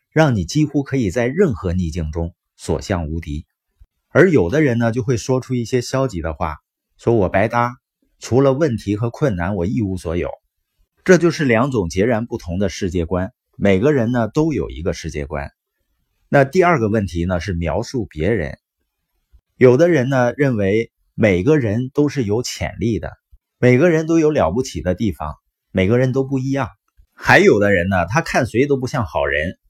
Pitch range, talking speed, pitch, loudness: 90-135 Hz, 260 characters per minute, 115 Hz, -18 LUFS